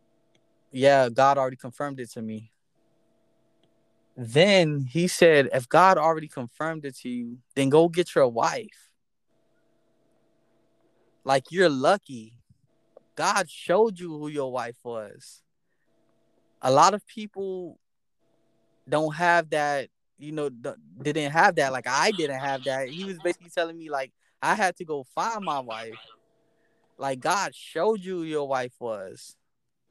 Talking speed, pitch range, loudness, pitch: 140 wpm, 130-170 Hz, -24 LUFS, 145 Hz